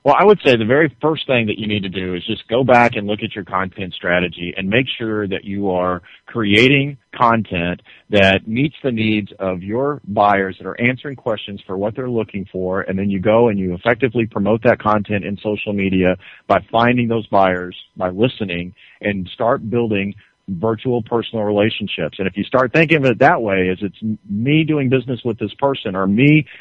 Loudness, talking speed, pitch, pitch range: -17 LUFS, 205 wpm, 105 Hz, 95-125 Hz